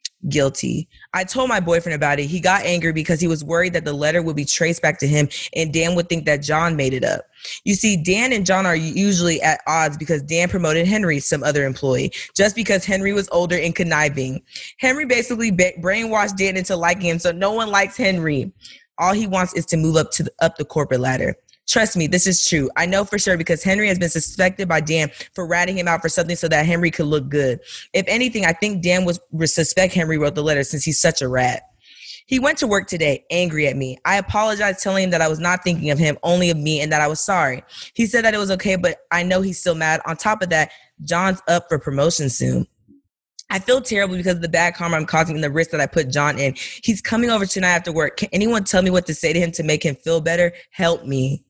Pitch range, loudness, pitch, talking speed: 155-190 Hz, -19 LUFS, 170 Hz, 245 wpm